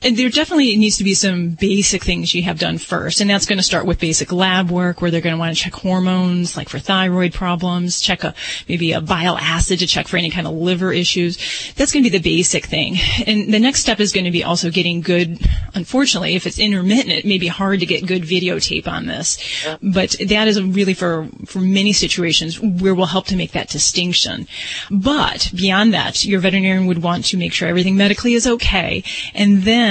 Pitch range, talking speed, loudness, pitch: 175-200 Hz, 225 wpm, -16 LUFS, 185 Hz